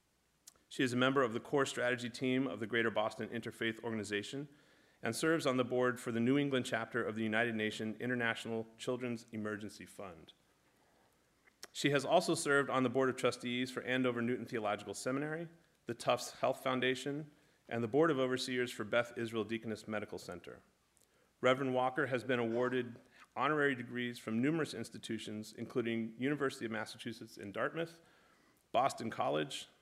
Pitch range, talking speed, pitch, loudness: 115-130 Hz, 160 wpm, 125 Hz, -36 LUFS